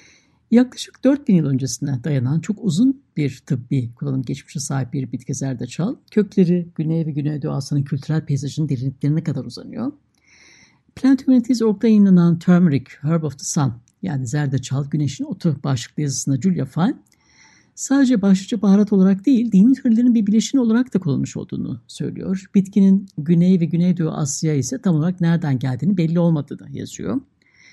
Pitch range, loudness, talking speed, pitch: 140-205 Hz, -19 LUFS, 150 wpm, 170 Hz